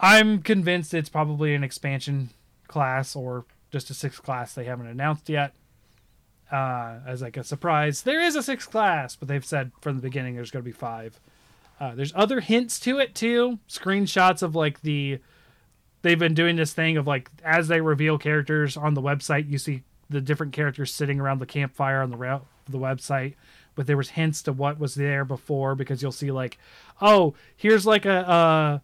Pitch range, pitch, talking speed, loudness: 135-160 Hz, 145 Hz, 195 wpm, -24 LUFS